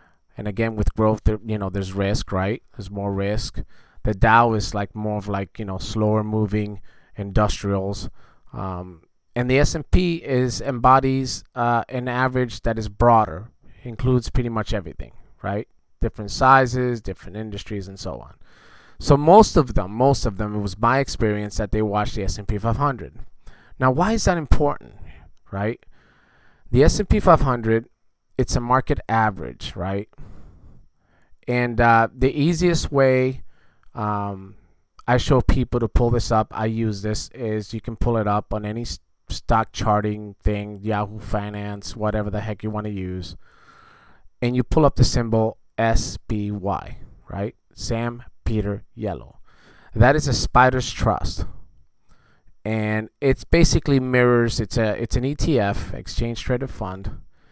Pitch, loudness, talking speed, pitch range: 110 Hz, -22 LUFS, 150 wpm, 105-125 Hz